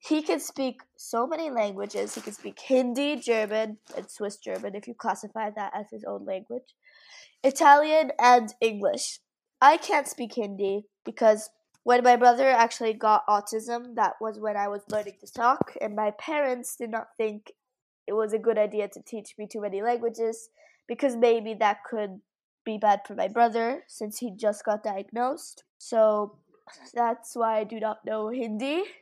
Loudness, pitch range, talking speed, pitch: -26 LUFS, 210-245 Hz, 170 wpm, 225 Hz